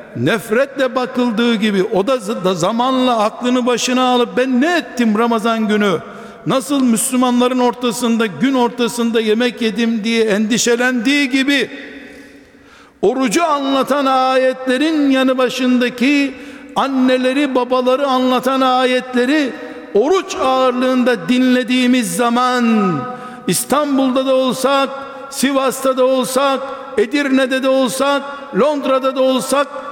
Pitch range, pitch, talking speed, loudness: 245-265 Hz, 255 Hz, 100 wpm, -15 LUFS